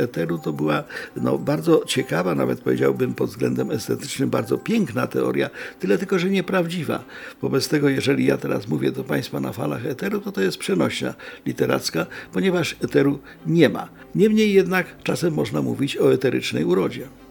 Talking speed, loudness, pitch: 160 wpm, -22 LUFS, 140 Hz